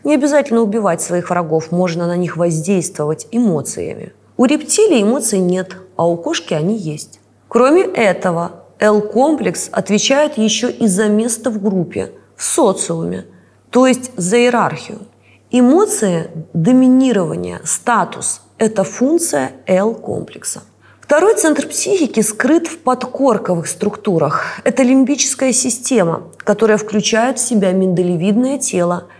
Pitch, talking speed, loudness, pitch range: 215 Hz, 115 wpm, -15 LUFS, 175-255 Hz